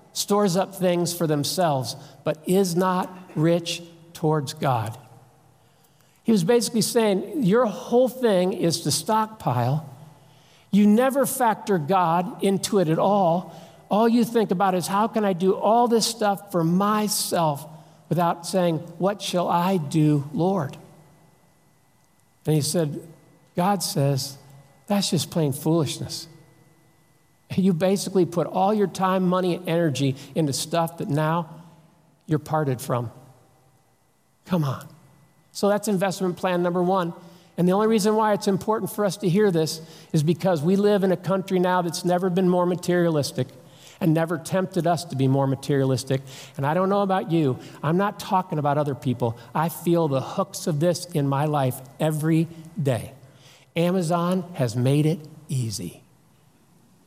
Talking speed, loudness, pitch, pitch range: 150 wpm, -23 LUFS, 170 Hz, 150-190 Hz